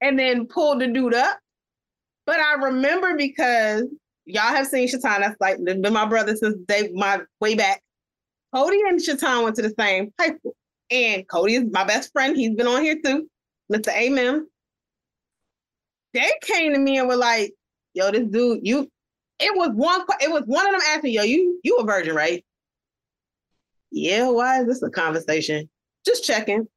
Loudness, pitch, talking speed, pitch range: -21 LUFS, 250 Hz, 180 wpm, 215-300 Hz